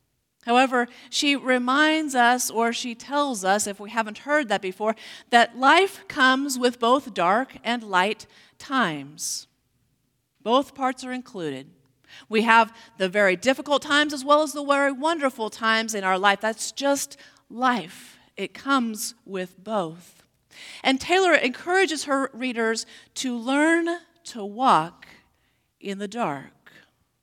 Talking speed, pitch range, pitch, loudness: 135 wpm, 205-275 Hz, 240 Hz, -23 LUFS